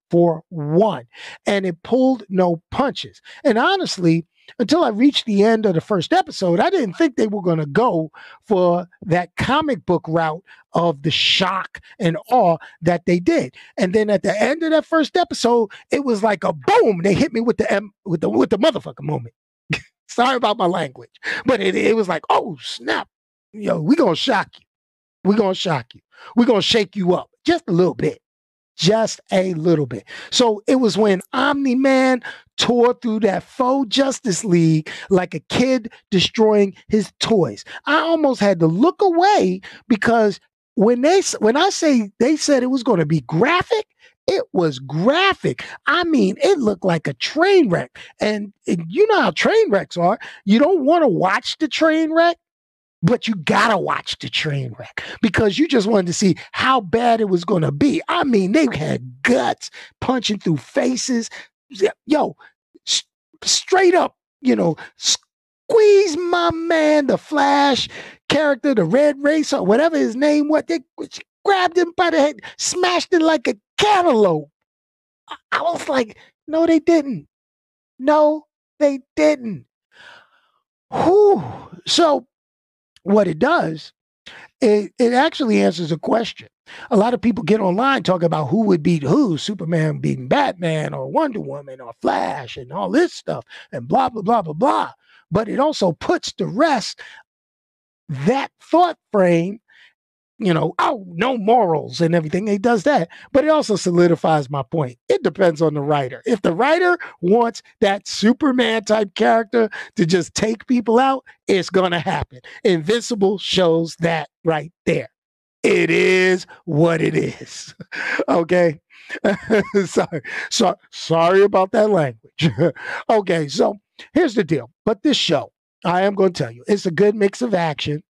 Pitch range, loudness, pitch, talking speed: 175-280 Hz, -18 LUFS, 215 Hz, 165 wpm